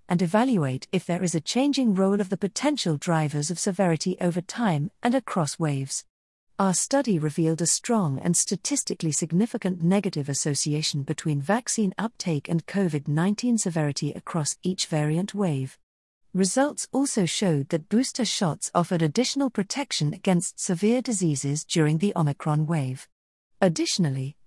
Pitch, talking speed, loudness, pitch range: 175 Hz, 135 wpm, -25 LUFS, 155-205 Hz